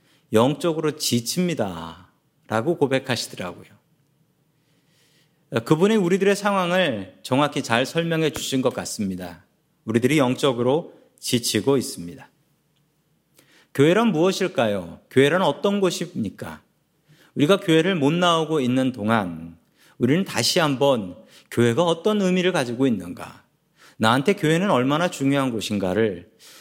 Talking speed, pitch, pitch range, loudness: 280 characters per minute, 145 Hz, 120-170 Hz, -21 LUFS